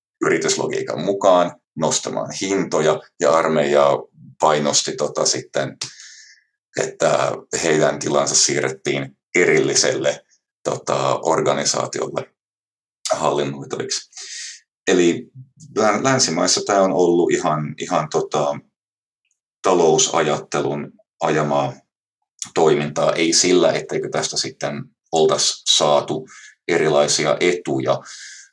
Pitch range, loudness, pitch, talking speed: 70-85 Hz, -19 LUFS, 75 Hz, 75 wpm